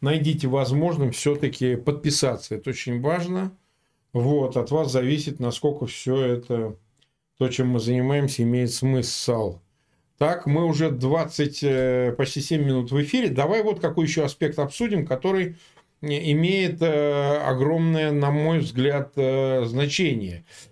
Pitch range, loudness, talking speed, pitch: 130-155 Hz, -23 LUFS, 120 wpm, 140 Hz